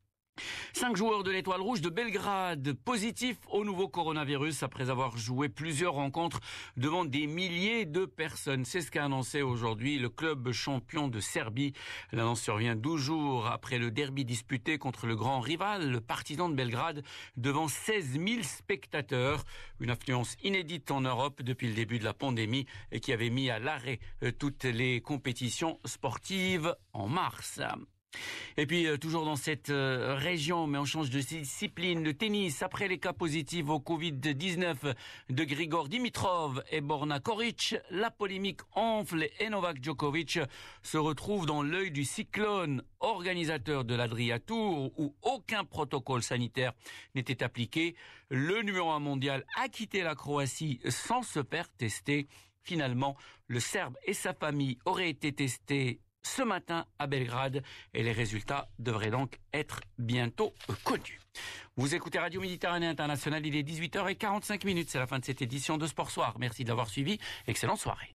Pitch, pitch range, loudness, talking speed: 145 Hz, 130-175 Hz, -34 LUFS, 160 wpm